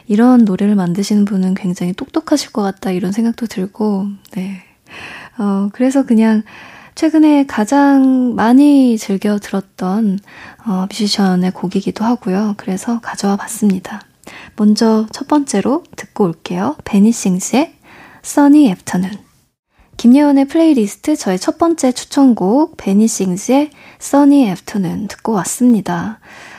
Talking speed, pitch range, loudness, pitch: 320 characters per minute, 195-265 Hz, -14 LUFS, 215 Hz